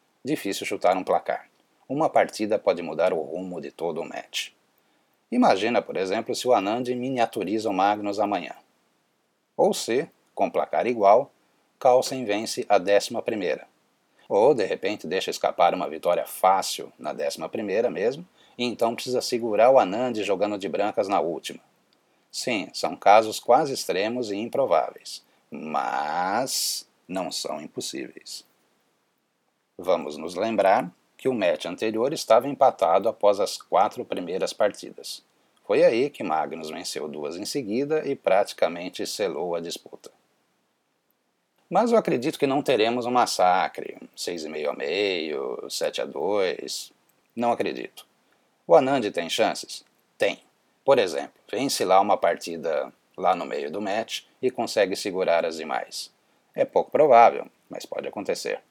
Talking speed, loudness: 140 wpm, -24 LUFS